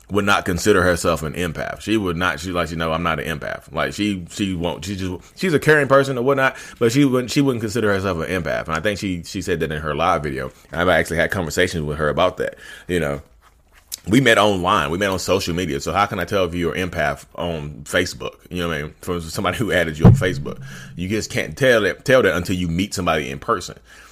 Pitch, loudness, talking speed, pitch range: 90 Hz, -20 LUFS, 255 wpm, 80-105 Hz